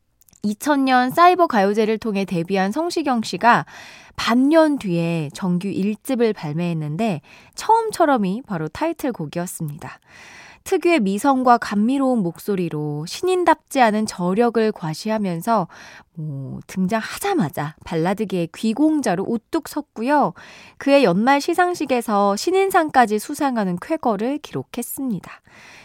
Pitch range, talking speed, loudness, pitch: 180-280 Hz, 285 characters per minute, -20 LUFS, 225 Hz